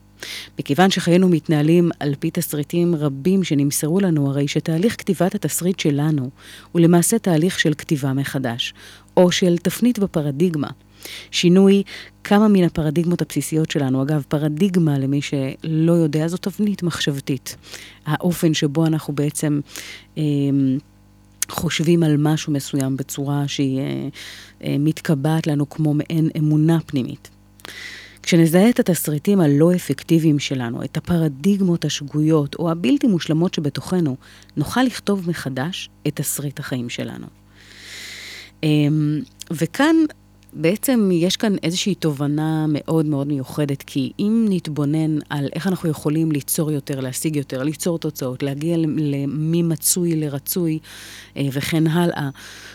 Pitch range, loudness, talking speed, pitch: 140-170 Hz, -20 LUFS, 120 wpm, 155 Hz